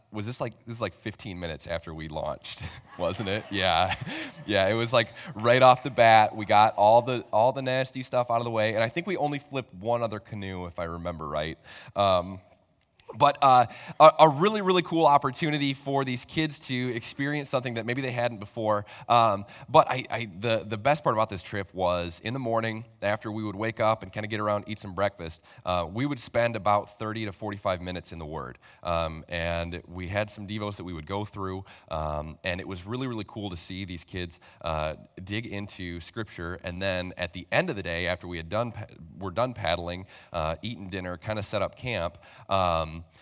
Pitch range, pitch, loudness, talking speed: 90-120 Hz, 105 Hz, -27 LUFS, 215 wpm